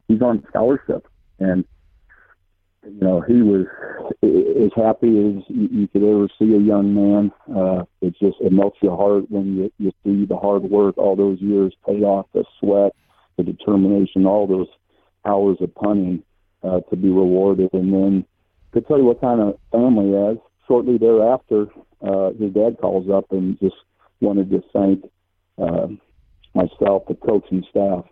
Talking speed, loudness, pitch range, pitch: 165 wpm, -18 LUFS, 95-105 Hz, 100 Hz